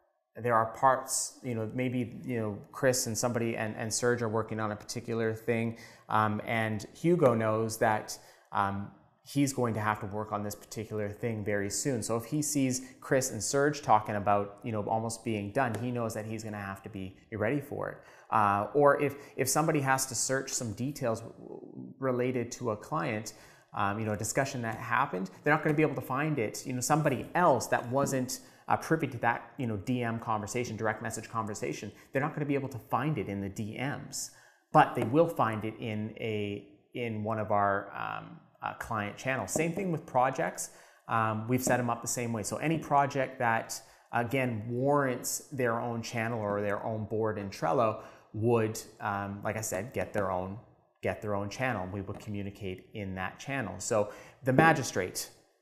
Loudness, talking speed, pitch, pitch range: -31 LUFS, 200 wpm, 115 Hz, 105-130 Hz